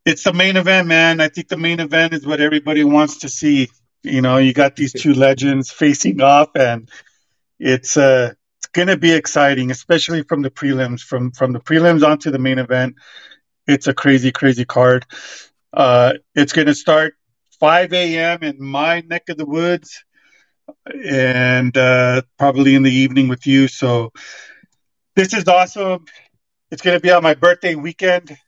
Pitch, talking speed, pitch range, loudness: 145 Hz, 170 wpm, 130-165 Hz, -14 LUFS